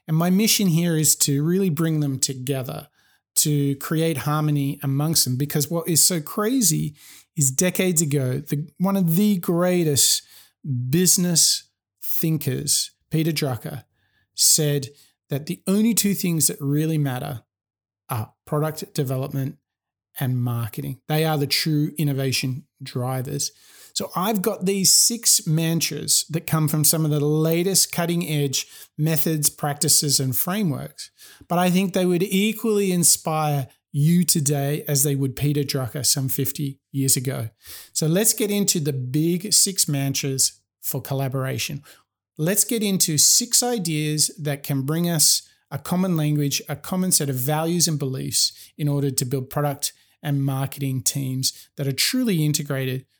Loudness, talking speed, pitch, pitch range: -21 LUFS, 145 wpm, 150 Hz, 140-170 Hz